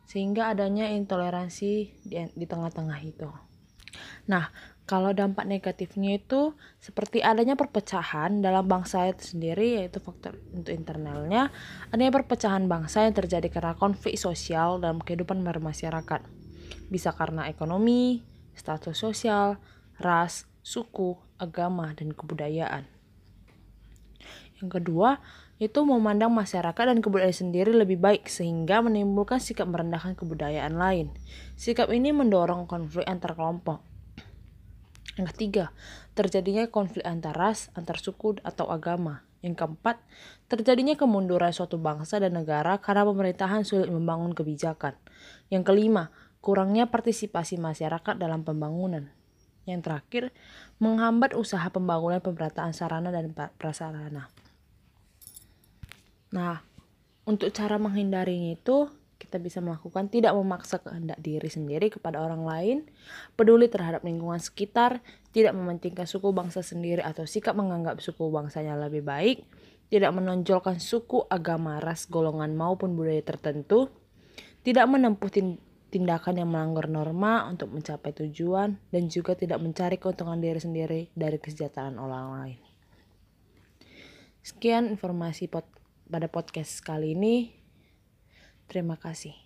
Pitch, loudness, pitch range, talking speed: 175 Hz, -28 LUFS, 160-205 Hz, 115 wpm